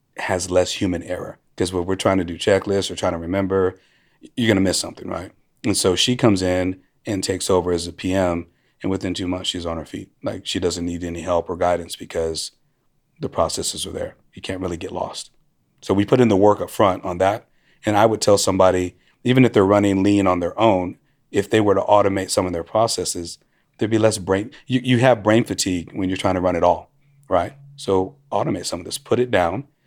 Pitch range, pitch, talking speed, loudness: 90-105 Hz, 95 Hz, 230 wpm, -20 LUFS